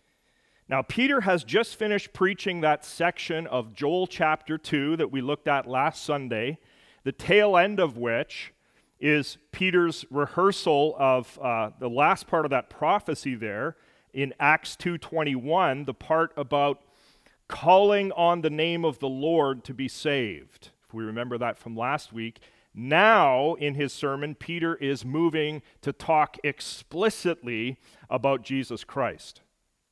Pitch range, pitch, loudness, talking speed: 135-165 Hz, 145 Hz, -26 LUFS, 140 wpm